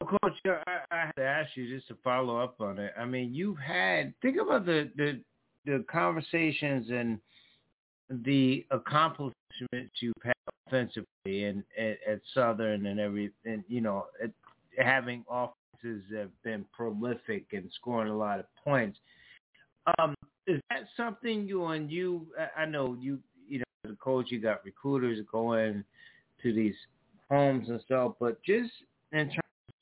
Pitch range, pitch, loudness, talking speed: 115-150 Hz, 125 Hz, -32 LUFS, 155 wpm